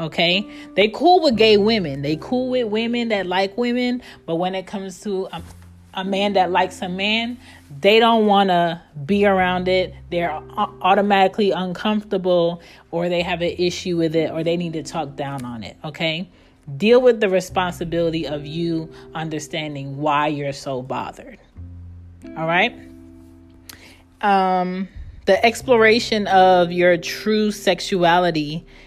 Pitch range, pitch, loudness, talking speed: 155-200 Hz, 180 Hz, -19 LUFS, 150 wpm